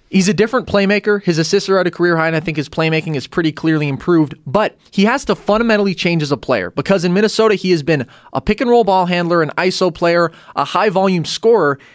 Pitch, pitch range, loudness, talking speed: 180 Hz, 160-205 Hz, -15 LUFS, 240 wpm